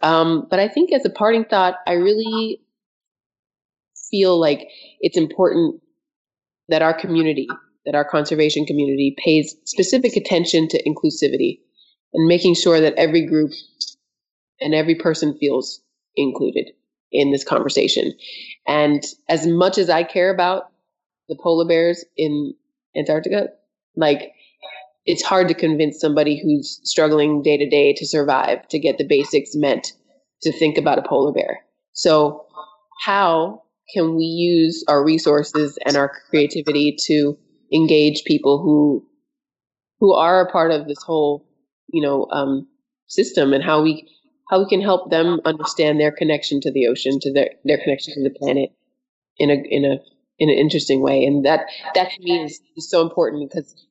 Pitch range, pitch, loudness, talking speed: 150-200 Hz, 160 Hz, -18 LUFS, 155 wpm